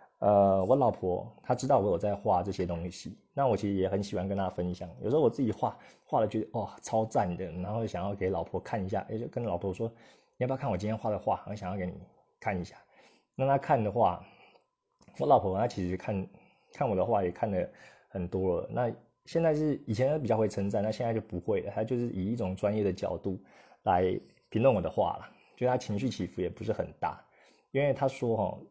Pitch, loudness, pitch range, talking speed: 105 Hz, -31 LUFS, 95-120 Hz, 320 characters per minute